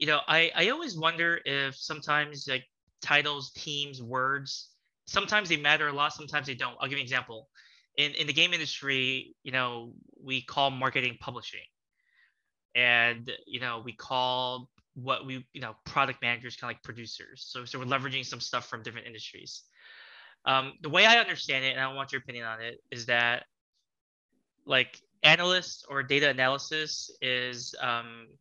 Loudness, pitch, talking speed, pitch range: -28 LUFS, 130 Hz, 175 wpm, 120-145 Hz